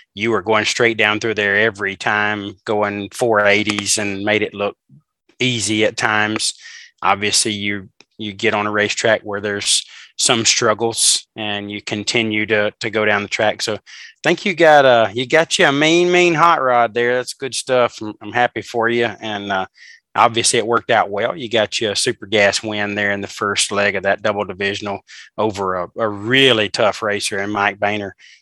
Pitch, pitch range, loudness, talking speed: 105 Hz, 100-115 Hz, -16 LUFS, 195 wpm